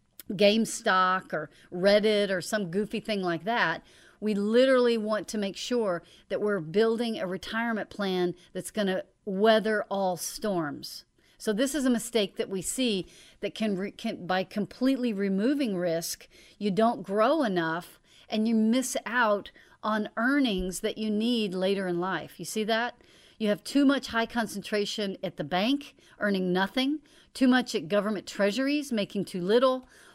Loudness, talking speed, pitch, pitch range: -28 LUFS, 160 wpm, 210 Hz, 190-230 Hz